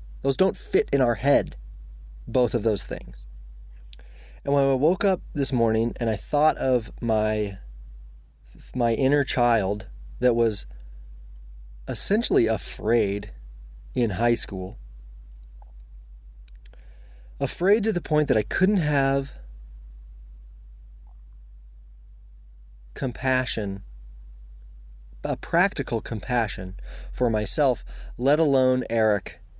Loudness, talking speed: -24 LUFS, 100 wpm